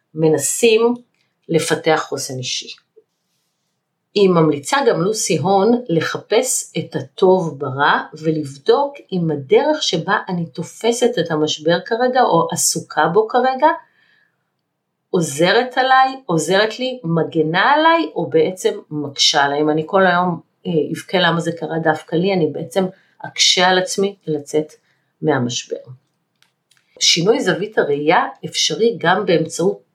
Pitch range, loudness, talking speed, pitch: 155-215 Hz, -17 LUFS, 120 wpm, 170 Hz